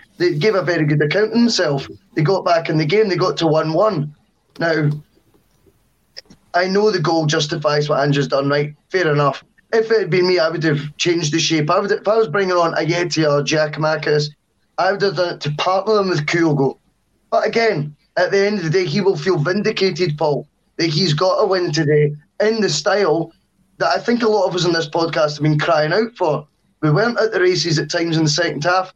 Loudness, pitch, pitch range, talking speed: -17 LUFS, 170 Hz, 155-190 Hz, 230 wpm